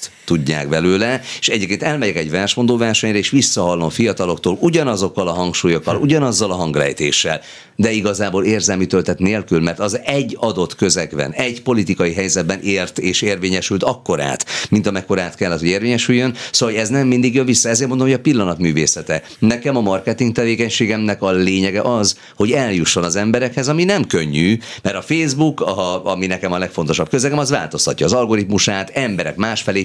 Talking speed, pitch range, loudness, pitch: 165 wpm, 95-125 Hz, -16 LUFS, 105 Hz